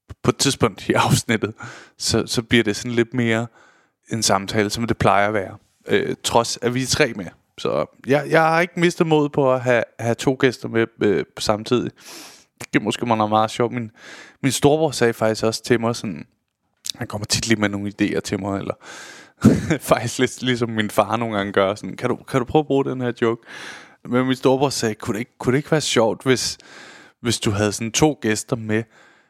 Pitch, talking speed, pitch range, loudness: 115 Hz, 220 wpm, 110-130 Hz, -20 LUFS